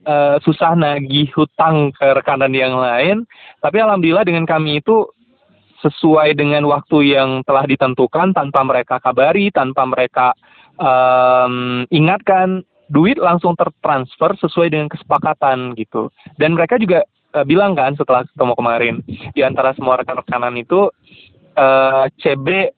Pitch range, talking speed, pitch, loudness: 130-170 Hz, 130 wpm, 145 Hz, -14 LUFS